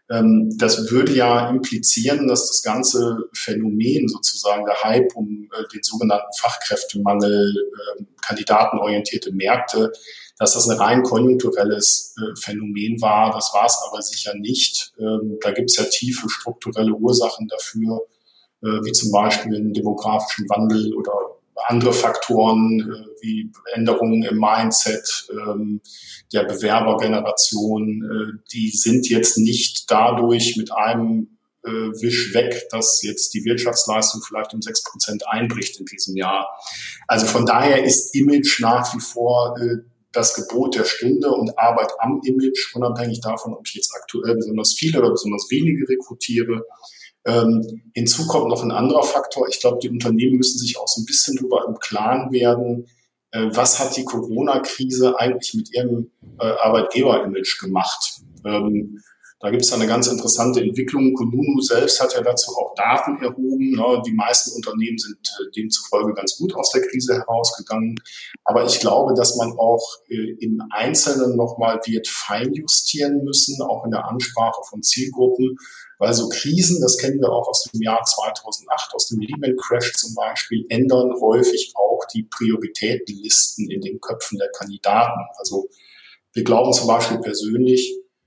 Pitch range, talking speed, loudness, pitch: 110-130 Hz, 145 wpm, -19 LUFS, 120 Hz